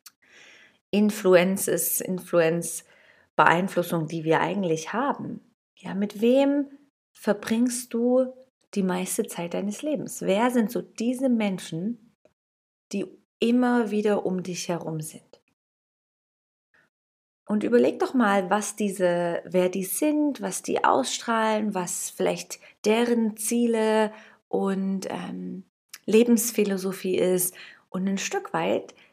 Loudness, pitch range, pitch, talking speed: -25 LUFS, 185-235 Hz, 205 Hz, 110 wpm